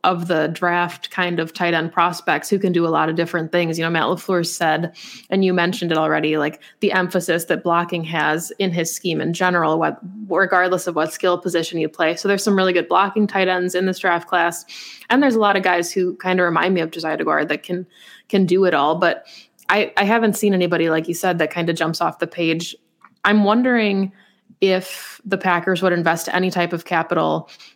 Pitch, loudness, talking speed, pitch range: 175 Hz, -19 LUFS, 225 wpm, 165-190 Hz